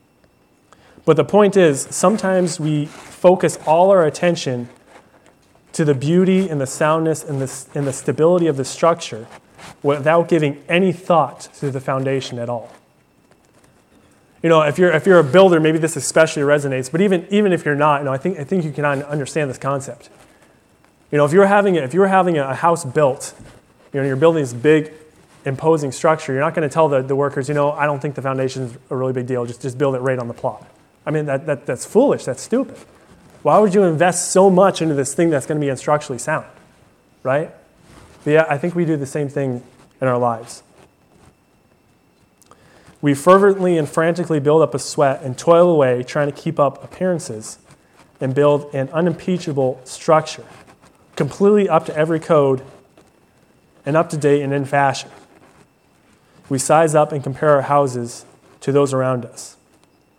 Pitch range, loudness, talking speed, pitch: 135-165 Hz, -17 LUFS, 190 wpm, 150 Hz